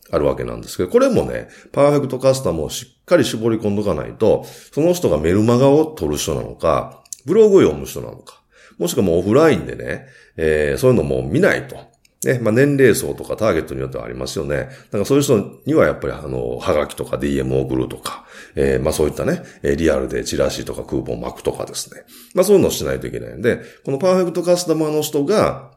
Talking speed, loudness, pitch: 445 characters per minute, -18 LUFS, 110 Hz